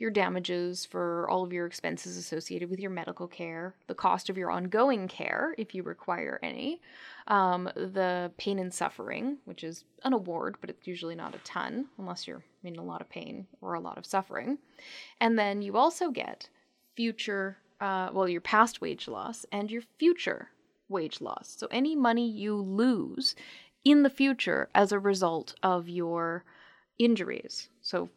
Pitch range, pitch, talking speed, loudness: 180-245 Hz, 200 Hz, 175 wpm, -31 LUFS